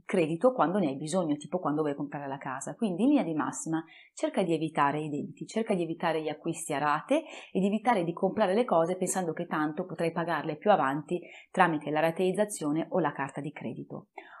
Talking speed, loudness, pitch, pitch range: 210 wpm, -30 LUFS, 165 Hz, 150-190 Hz